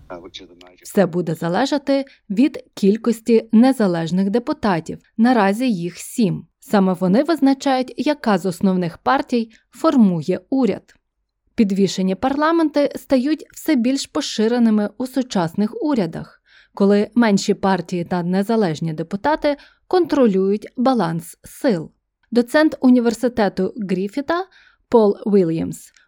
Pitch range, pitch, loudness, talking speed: 190-270 Hz, 225 Hz, -19 LUFS, 95 wpm